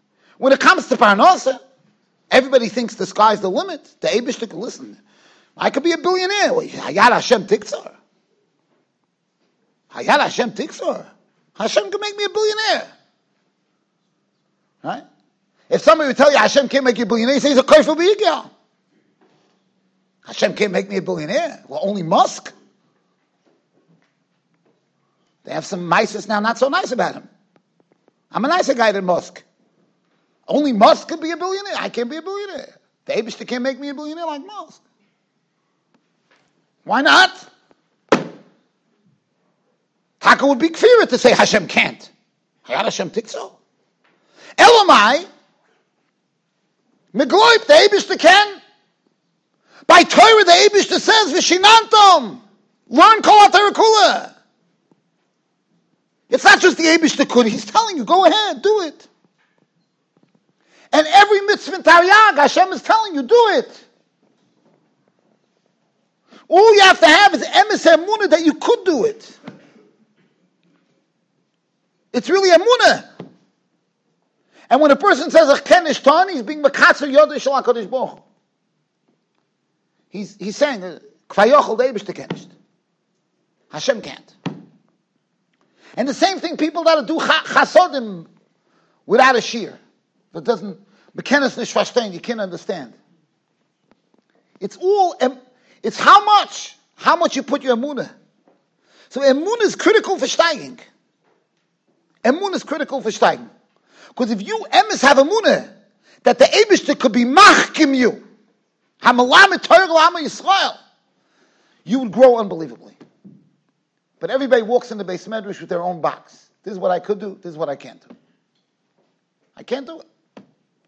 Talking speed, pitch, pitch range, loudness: 130 wpm, 300 Hz, 245-370 Hz, -14 LUFS